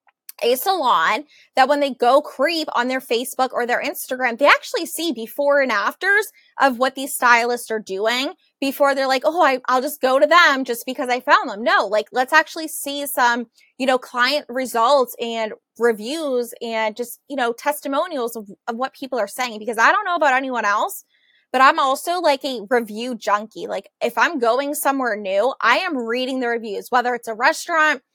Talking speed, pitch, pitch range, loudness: 195 wpm, 260 Hz, 240-290 Hz, -19 LUFS